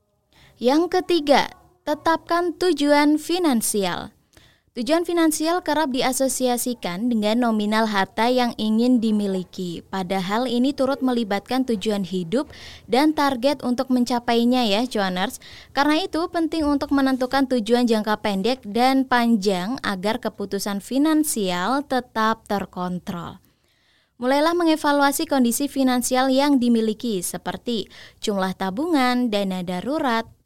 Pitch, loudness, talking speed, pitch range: 245 Hz, -21 LUFS, 105 wpm, 215-280 Hz